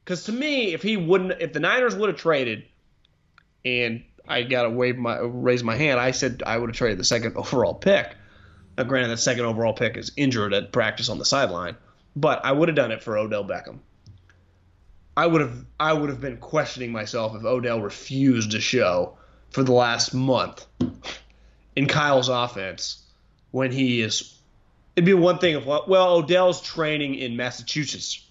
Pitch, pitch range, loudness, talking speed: 125 Hz, 110-150 Hz, -23 LUFS, 185 wpm